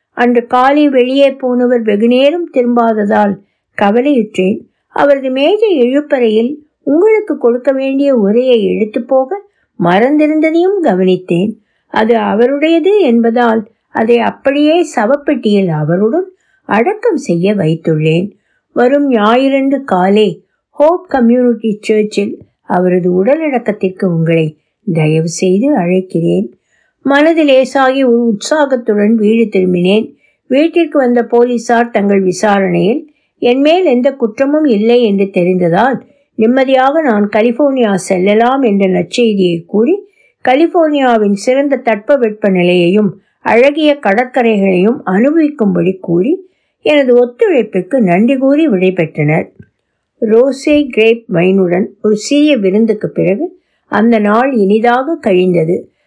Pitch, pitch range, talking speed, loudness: 235 Hz, 200-280 Hz, 90 wpm, -11 LUFS